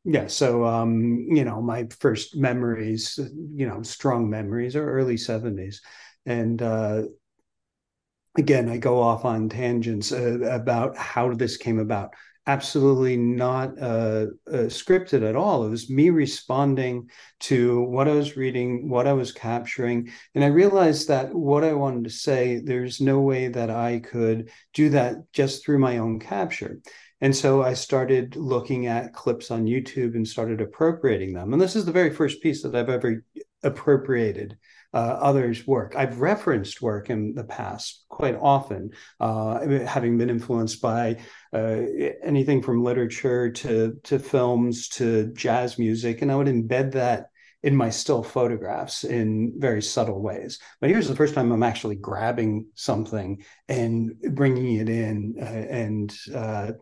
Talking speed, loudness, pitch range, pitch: 160 wpm, -24 LUFS, 115-135 Hz, 120 Hz